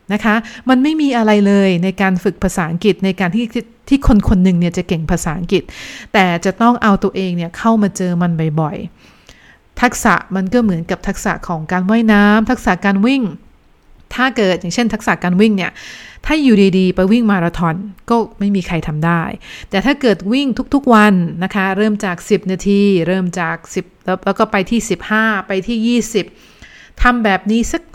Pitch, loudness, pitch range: 200 Hz, -15 LUFS, 185-225 Hz